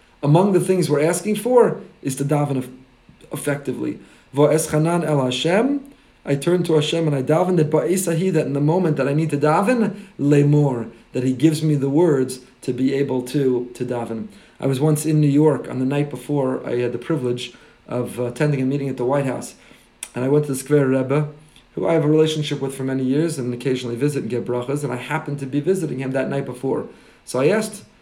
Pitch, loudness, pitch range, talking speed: 145 Hz, -20 LUFS, 130-155 Hz, 215 wpm